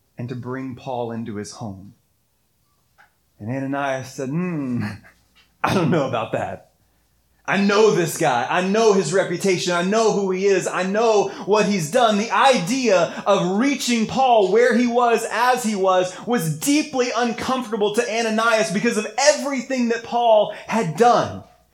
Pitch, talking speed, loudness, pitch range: 205 Hz, 155 wpm, -19 LUFS, 155-240 Hz